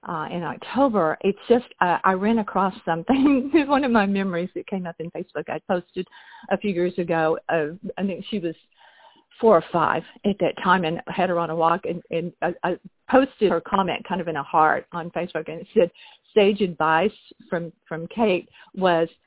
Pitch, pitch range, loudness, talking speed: 185 Hz, 165-215 Hz, -23 LUFS, 200 wpm